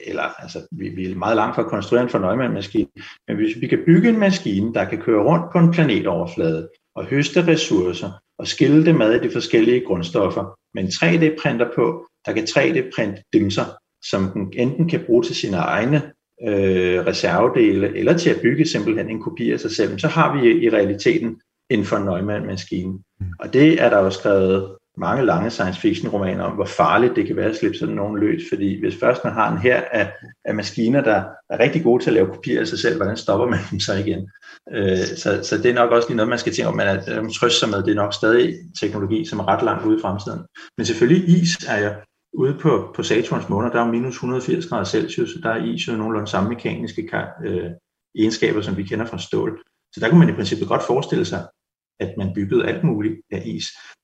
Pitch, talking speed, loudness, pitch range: 115 Hz, 225 wpm, -19 LUFS, 100-160 Hz